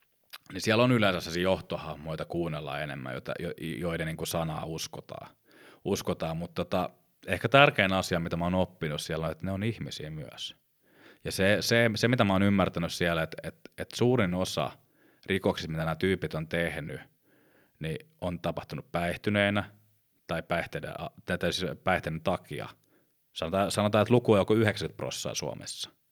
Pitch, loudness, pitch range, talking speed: 95 Hz, -29 LUFS, 80-105 Hz, 160 wpm